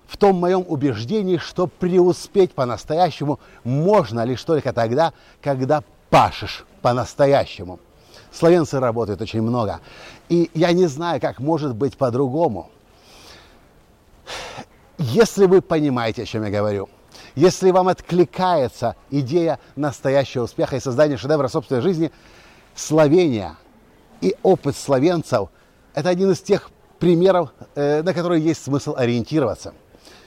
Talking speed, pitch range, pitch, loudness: 115 wpm, 125-175 Hz, 150 Hz, -19 LUFS